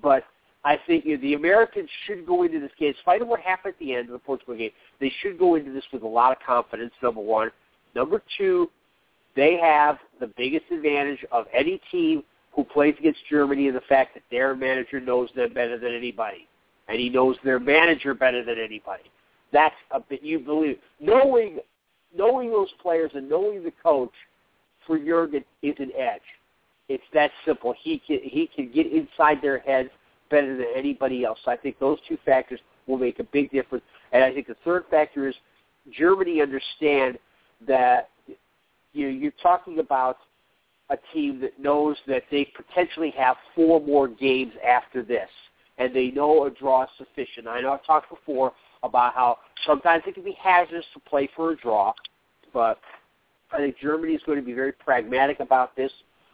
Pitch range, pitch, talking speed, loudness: 130-175 Hz, 145 Hz, 185 wpm, -24 LUFS